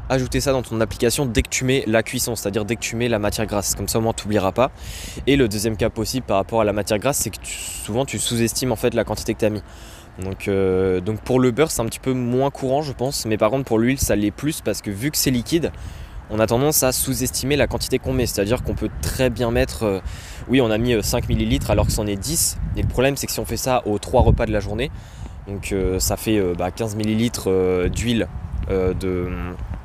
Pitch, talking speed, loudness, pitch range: 110 Hz, 265 wpm, -21 LUFS, 100-125 Hz